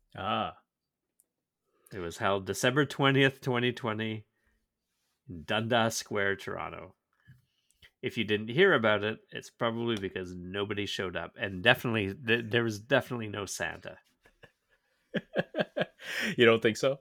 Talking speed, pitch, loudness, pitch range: 120 wpm, 110 Hz, -30 LUFS, 100-120 Hz